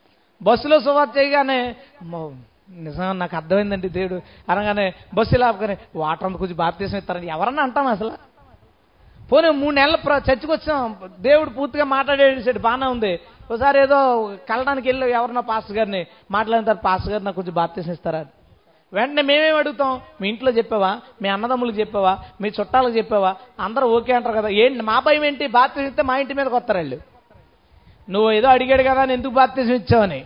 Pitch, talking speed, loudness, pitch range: 235 Hz, 145 wpm, -19 LUFS, 195-270 Hz